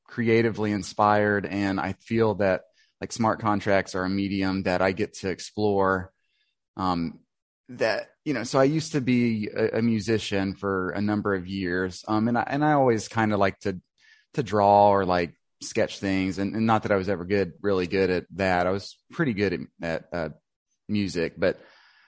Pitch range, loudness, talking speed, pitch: 95-110 Hz, -25 LUFS, 195 wpm, 100 Hz